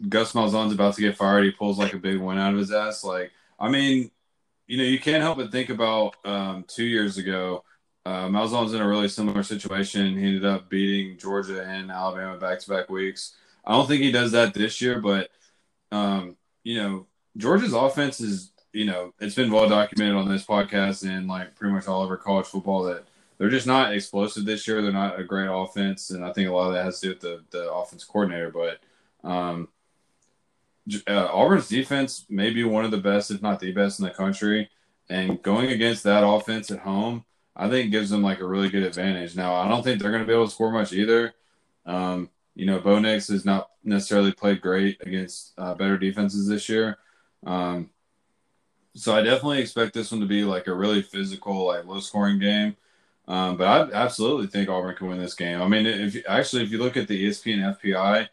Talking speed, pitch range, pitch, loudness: 215 wpm, 95-110 Hz, 100 Hz, -24 LUFS